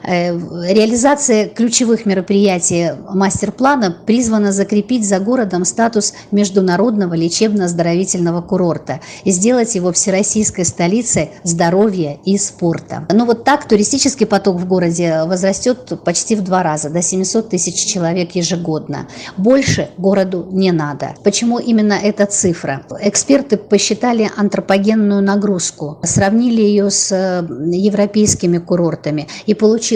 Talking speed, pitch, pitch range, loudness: 110 wpm, 195 Hz, 175-215 Hz, -14 LUFS